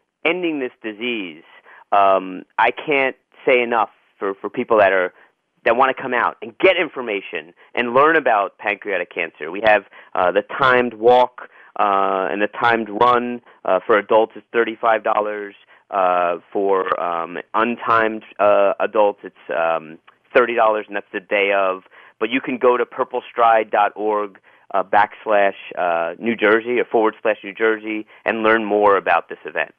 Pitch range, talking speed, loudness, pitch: 100-120 Hz, 160 wpm, -19 LUFS, 110 Hz